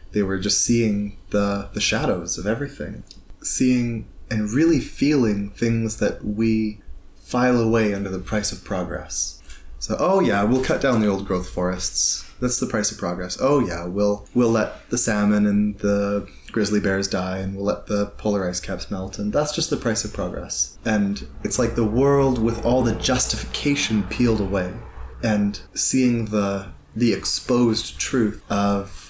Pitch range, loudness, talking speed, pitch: 95-115 Hz, -22 LUFS, 170 wpm, 105 Hz